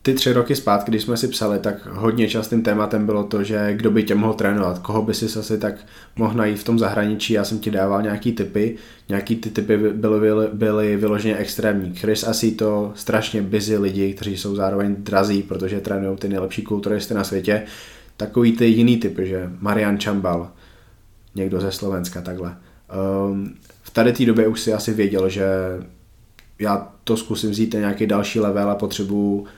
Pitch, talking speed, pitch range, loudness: 105 Hz, 185 wpm, 100-110 Hz, -20 LUFS